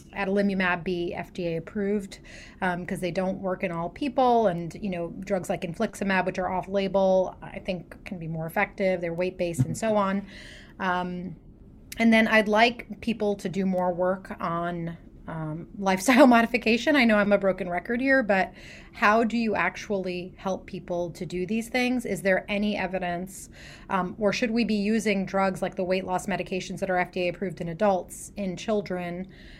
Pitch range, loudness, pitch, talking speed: 180-205 Hz, -26 LUFS, 190 Hz, 180 wpm